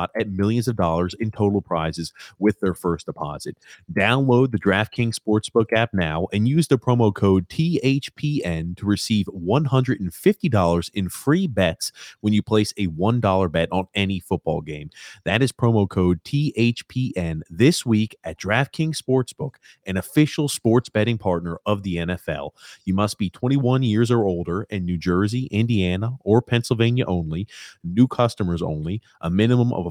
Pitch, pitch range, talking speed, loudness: 105 Hz, 90-125 Hz, 165 wpm, -22 LUFS